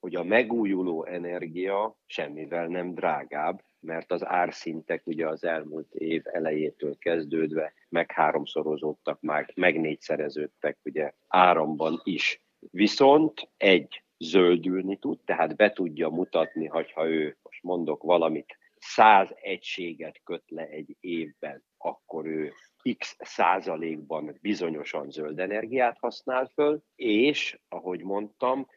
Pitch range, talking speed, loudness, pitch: 80-100 Hz, 115 wpm, -27 LUFS, 85 Hz